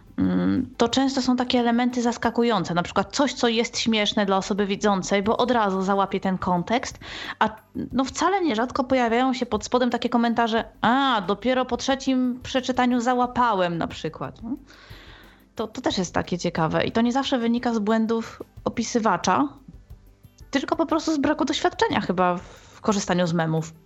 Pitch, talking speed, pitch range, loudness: 235 Hz, 160 wpm, 200-260 Hz, -23 LUFS